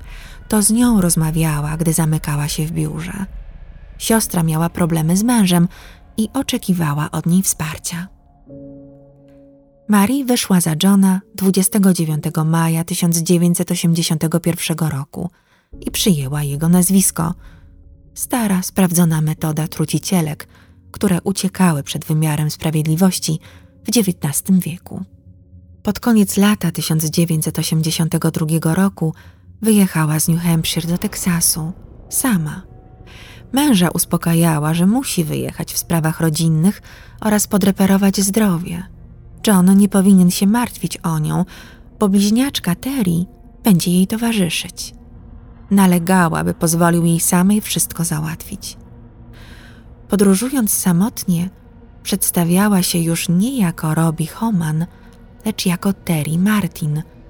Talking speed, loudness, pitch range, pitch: 105 wpm, -16 LUFS, 160-195 Hz, 170 Hz